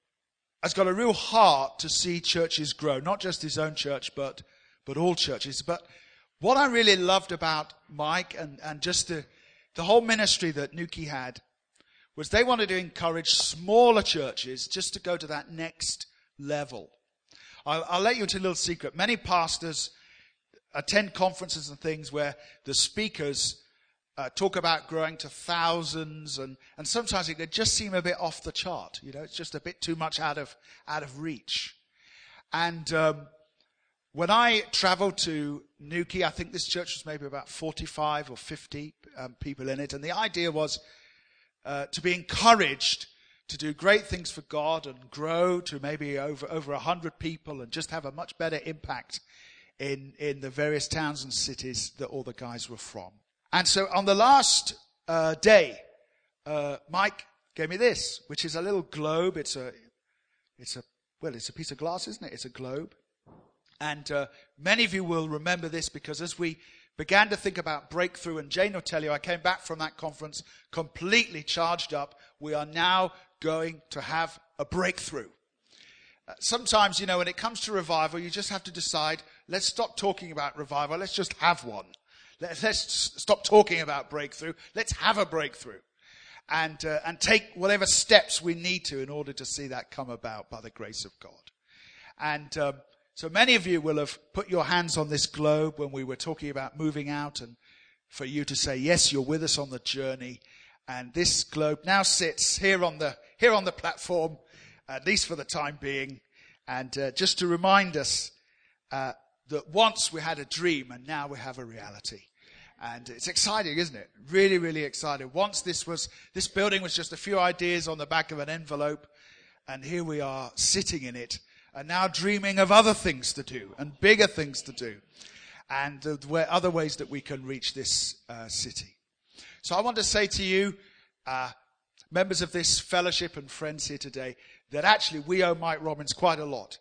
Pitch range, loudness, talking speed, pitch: 145-180 Hz, -27 LUFS, 190 wpm, 160 Hz